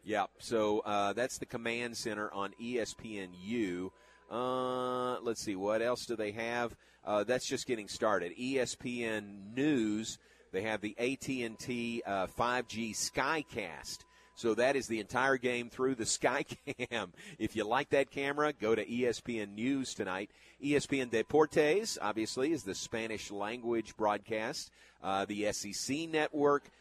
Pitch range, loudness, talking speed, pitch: 105-125 Hz, -35 LUFS, 150 wpm, 115 Hz